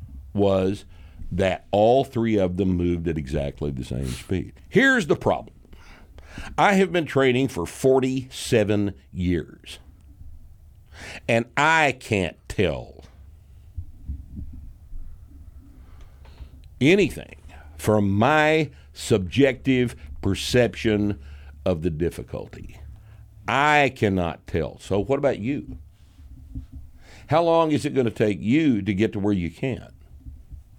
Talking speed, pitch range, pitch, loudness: 105 wpm, 80-110 Hz, 90 Hz, -22 LUFS